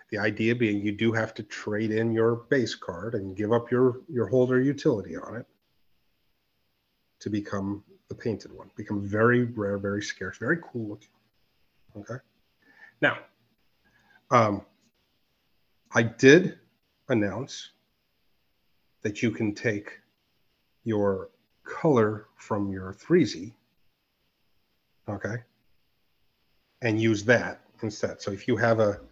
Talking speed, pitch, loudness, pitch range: 120 wpm, 110 Hz, -26 LUFS, 105-115 Hz